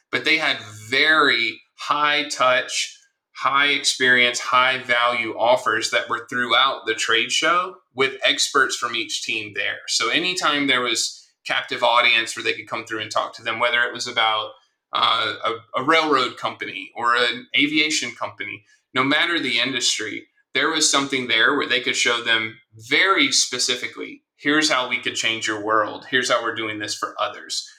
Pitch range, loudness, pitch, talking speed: 115-150 Hz, -19 LUFS, 125 Hz, 175 wpm